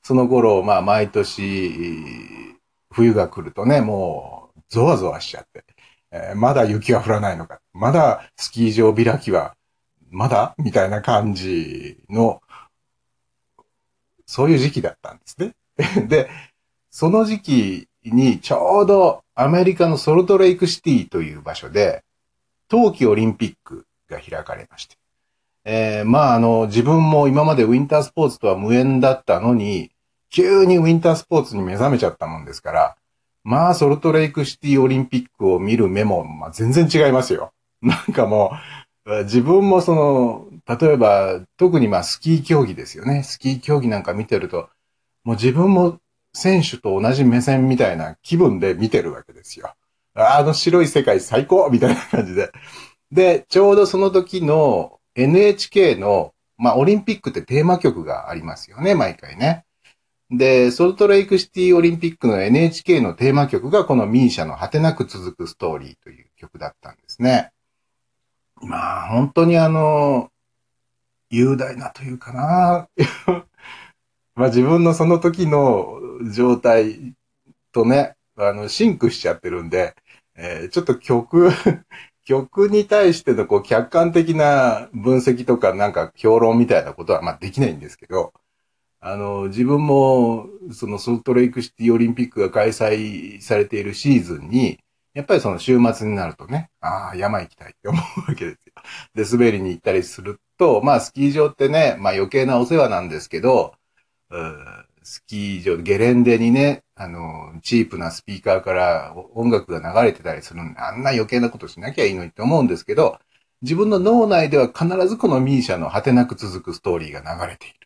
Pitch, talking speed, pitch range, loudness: 130 Hz, 330 characters per minute, 115-165 Hz, -17 LUFS